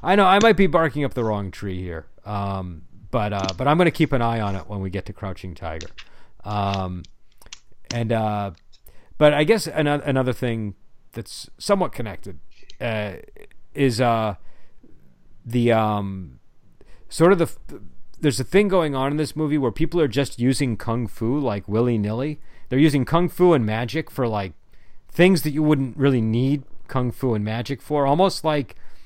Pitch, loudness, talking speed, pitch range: 120 Hz, -22 LUFS, 180 wpm, 100-150 Hz